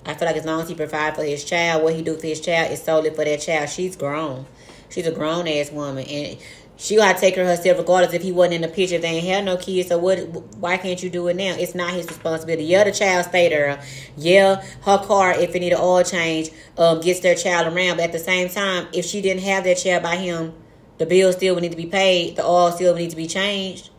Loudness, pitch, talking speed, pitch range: -19 LUFS, 175 Hz, 275 wpm, 160-185 Hz